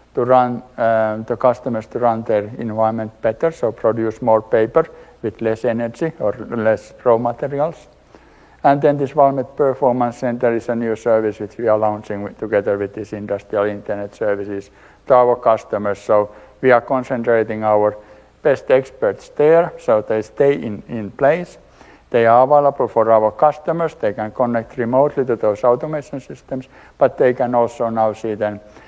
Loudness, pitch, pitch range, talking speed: -18 LUFS, 115 Hz, 105-130 Hz, 165 wpm